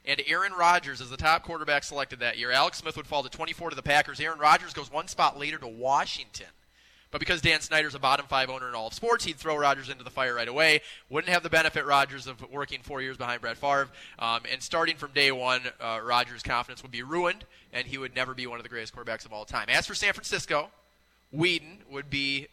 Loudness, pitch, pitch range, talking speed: -27 LUFS, 140 Hz, 125-160 Hz, 240 wpm